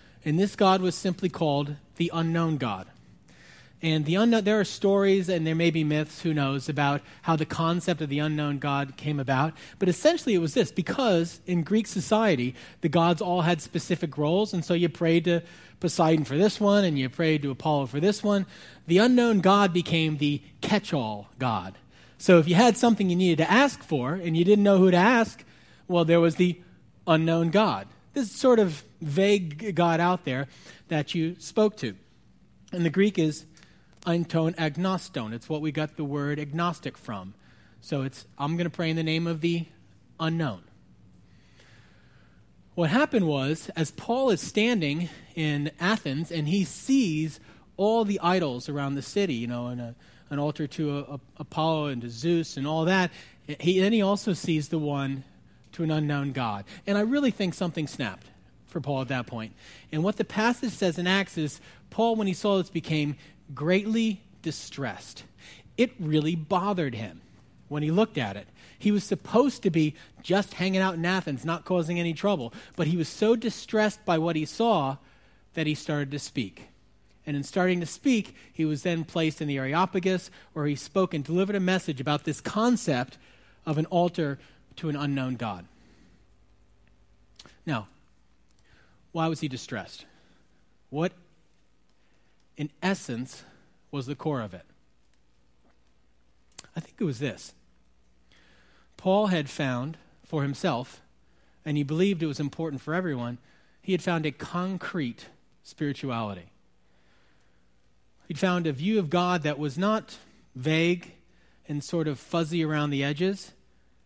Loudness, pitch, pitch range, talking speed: -26 LUFS, 160 Hz, 140-185 Hz, 170 wpm